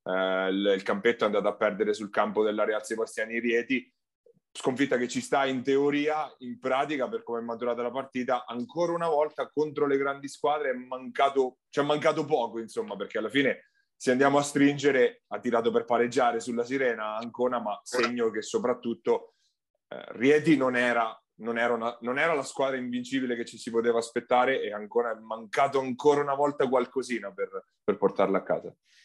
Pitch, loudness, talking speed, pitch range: 125 Hz, -28 LUFS, 190 wpm, 115-145 Hz